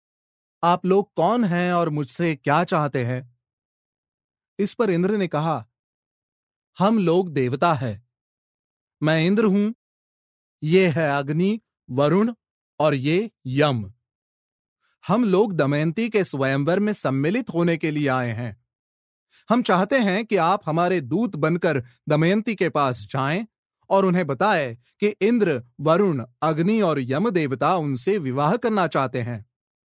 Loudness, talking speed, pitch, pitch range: -22 LUFS, 135 wpm, 160 Hz, 135-195 Hz